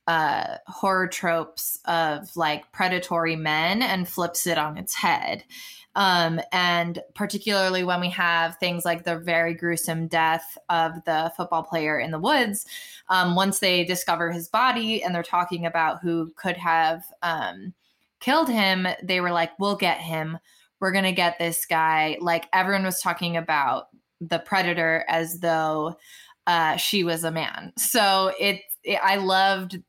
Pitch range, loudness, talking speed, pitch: 165-190 Hz, -23 LUFS, 160 wpm, 175 Hz